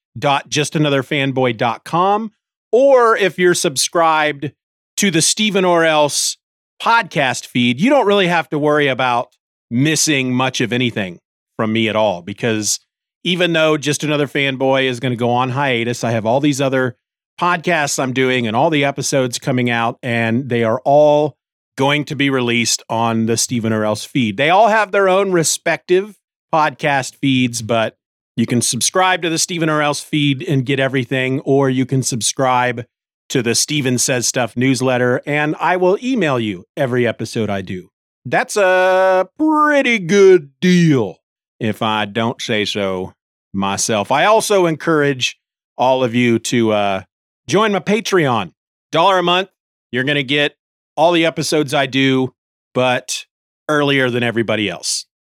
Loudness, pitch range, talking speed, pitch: -16 LUFS, 120-165 Hz, 160 wpm, 135 Hz